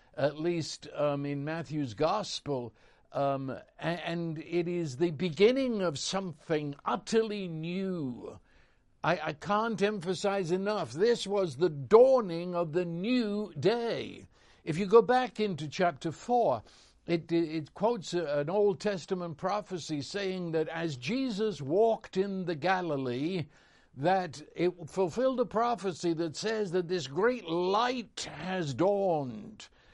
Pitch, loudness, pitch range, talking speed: 180 Hz, -31 LUFS, 160-205 Hz, 130 wpm